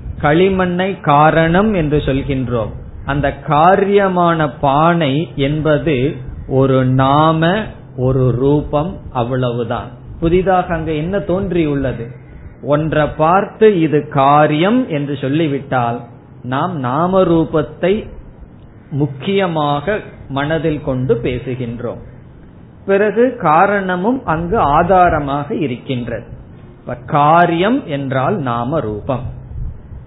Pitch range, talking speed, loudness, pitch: 130-170 Hz, 80 wpm, -15 LUFS, 145 Hz